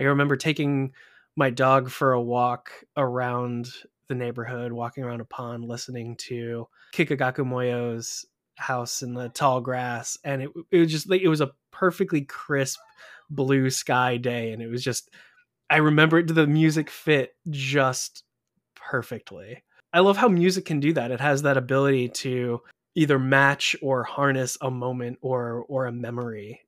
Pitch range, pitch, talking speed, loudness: 125-150 Hz, 130 Hz, 160 wpm, -24 LUFS